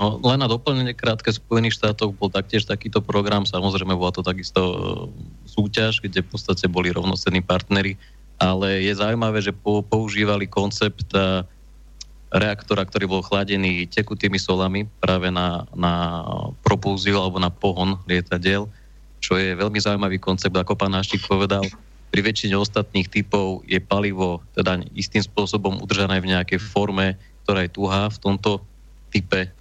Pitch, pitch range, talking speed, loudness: 100 Hz, 95-105 Hz, 140 wpm, -22 LUFS